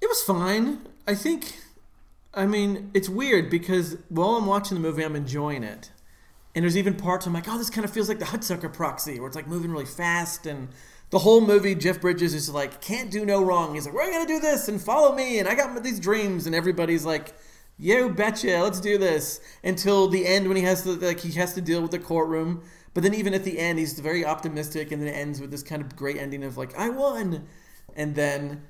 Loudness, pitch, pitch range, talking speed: -25 LUFS, 180 Hz, 155-205 Hz, 240 wpm